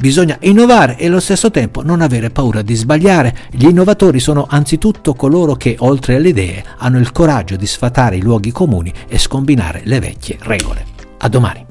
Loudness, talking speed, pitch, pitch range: -12 LUFS, 180 wpm, 130 Hz, 115-160 Hz